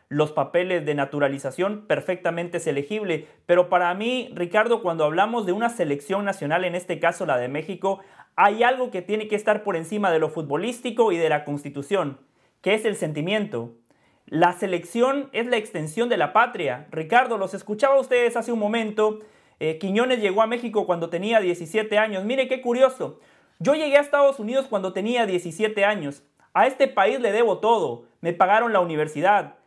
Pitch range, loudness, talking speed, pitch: 170-230 Hz, -23 LUFS, 180 wpm, 195 Hz